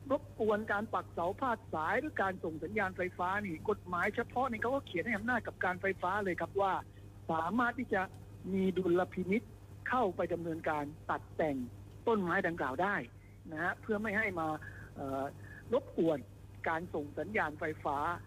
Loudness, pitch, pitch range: -35 LUFS, 180 Hz, 145-205 Hz